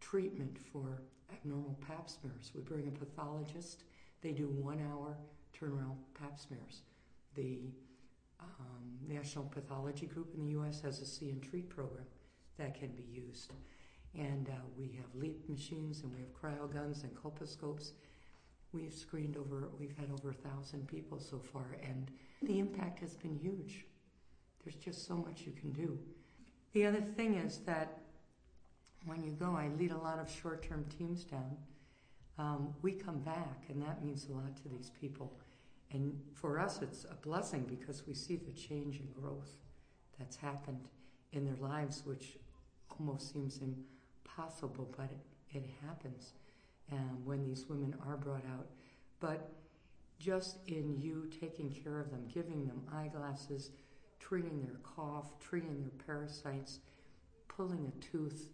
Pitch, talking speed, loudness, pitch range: 145 Hz, 155 wpm, -45 LUFS, 135-160 Hz